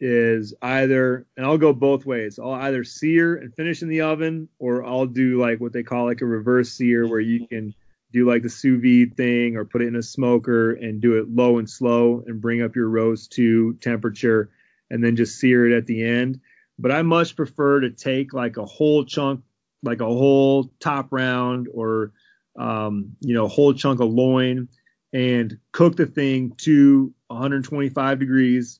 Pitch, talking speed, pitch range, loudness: 125 Hz, 195 wpm, 115-135 Hz, -20 LUFS